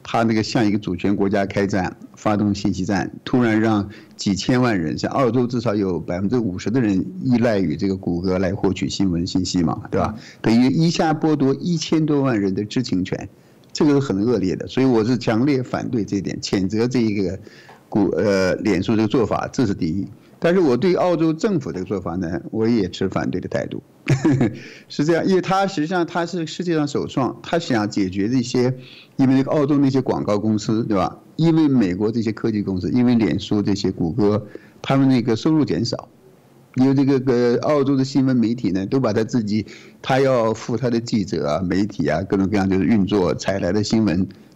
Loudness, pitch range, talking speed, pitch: -20 LUFS, 100-135 Hz, 305 characters per minute, 110 Hz